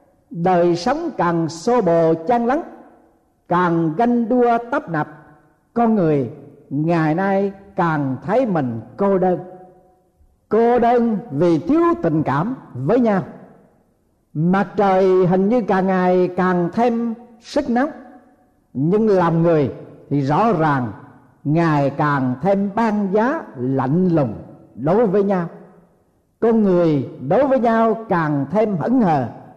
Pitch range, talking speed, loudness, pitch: 155-230 Hz, 130 wpm, -18 LUFS, 185 Hz